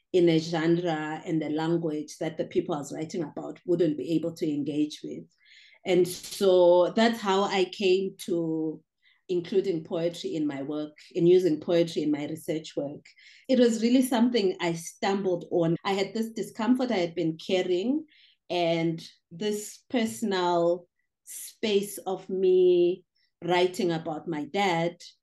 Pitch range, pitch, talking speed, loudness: 165-200 Hz, 175 Hz, 150 wpm, -27 LUFS